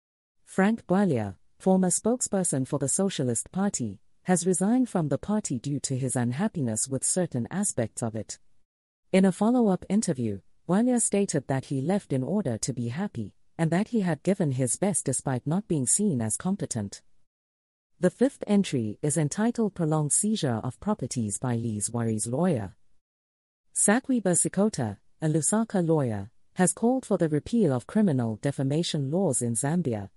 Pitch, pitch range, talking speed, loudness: 150 Hz, 120-195 Hz, 155 wpm, -26 LUFS